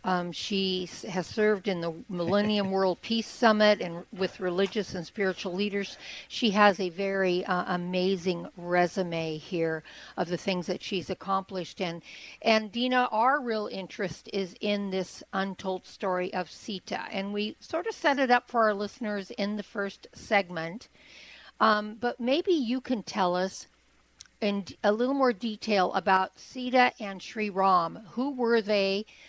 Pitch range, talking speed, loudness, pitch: 185-215 Hz, 160 wpm, -29 LUFS, 195 Hz